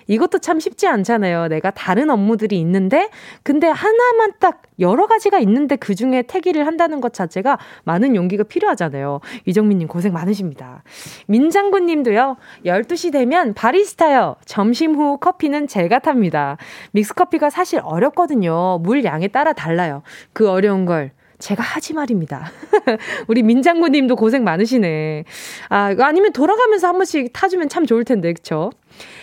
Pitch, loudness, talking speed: 245 Hz, -16 LUFS, 335 characters per minute